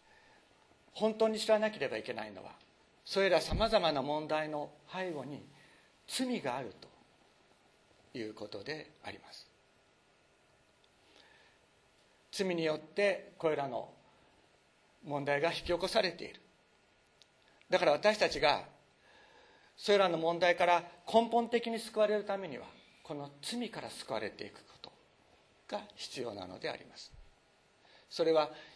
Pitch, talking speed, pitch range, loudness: 195 Hz, 245 characters per minute, 160-220 Hz, -34 LUFS